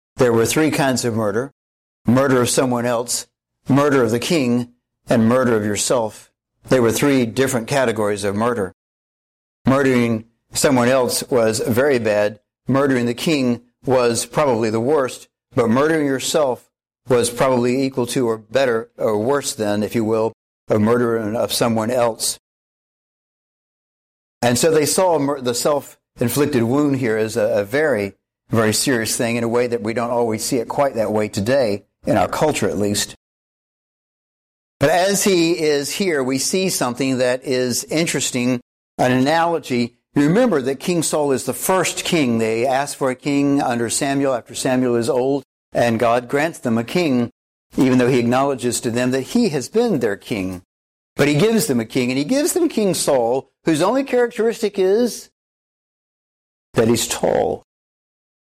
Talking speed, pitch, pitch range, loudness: 165 wpm, 125 Hz, 115-140 Hz, -18 LUFS